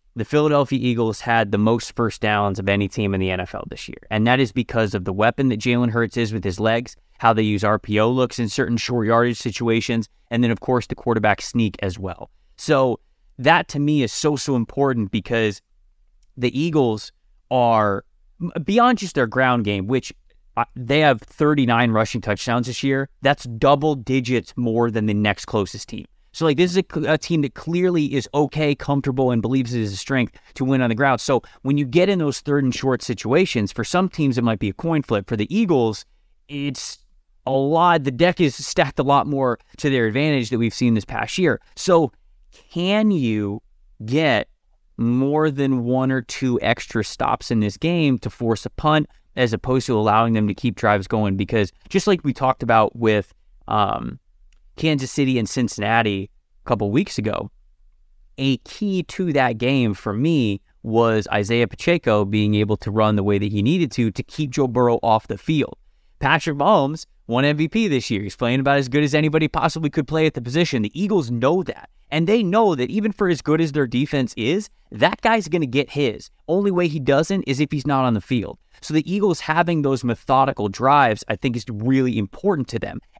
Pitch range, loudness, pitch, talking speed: 110-150 Hz, -20 LUFS, 125 Hz, 205 wpm